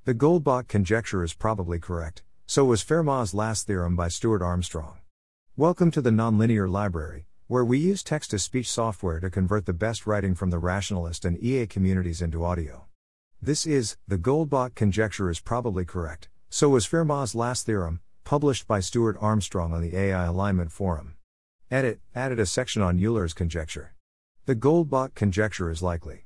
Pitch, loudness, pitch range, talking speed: 100 Hz, -26 LUFS, 85-120 Hz, 165 wpm